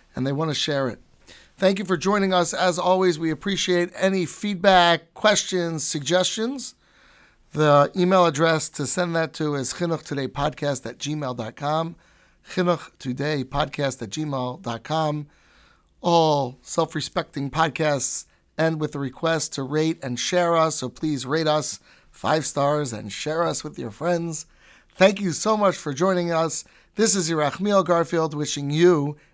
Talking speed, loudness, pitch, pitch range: 145 wpm, -23 LUFS, 160 Hz, 145-175 Hz